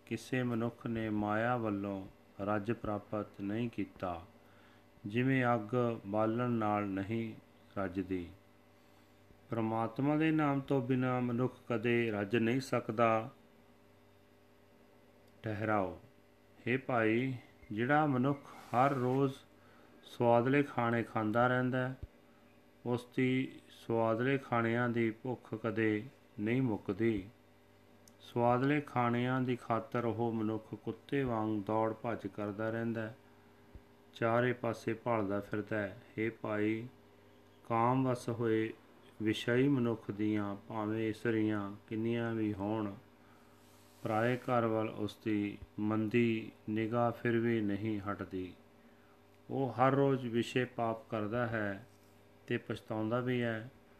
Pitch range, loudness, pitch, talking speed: 100-120 Hz, -35 LUFS, 110 Hz, 105 wpm